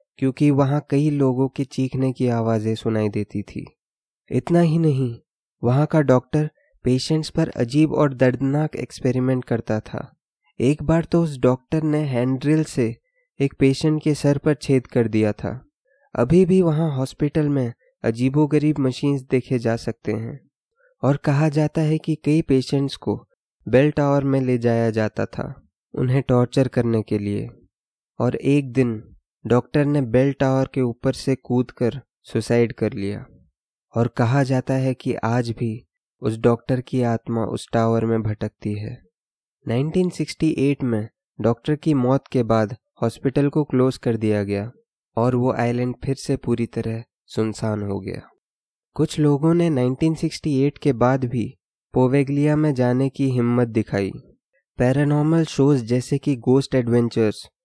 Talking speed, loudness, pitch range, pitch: 150 wpm, -21 LUFS, 115-145 Hz, 130 Hz